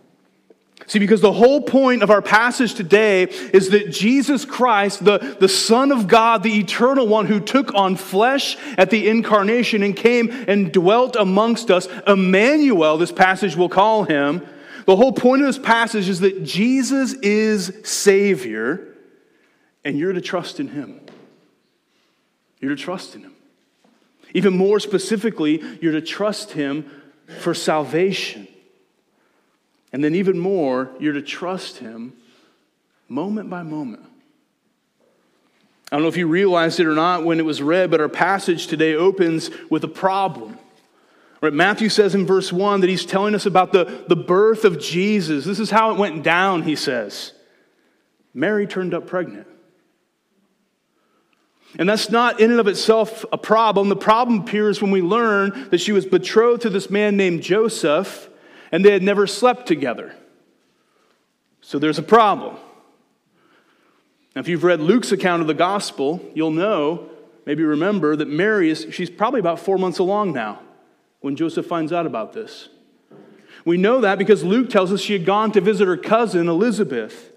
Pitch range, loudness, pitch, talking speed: 175-225 Hz, -18 LUFS, 200 Hz, 160 wpm